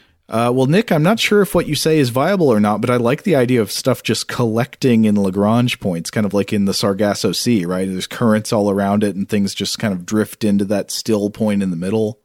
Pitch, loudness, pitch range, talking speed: 110 Hz, -17 LUFS, 100-125 Hz, 255 wpm